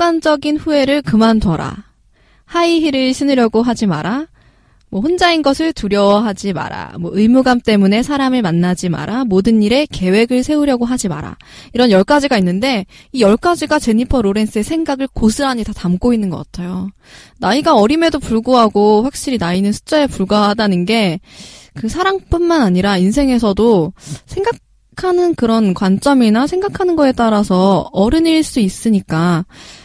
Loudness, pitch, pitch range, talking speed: -14 LUFS, 225 Hz, 200-285 Hz, 340 characters per minute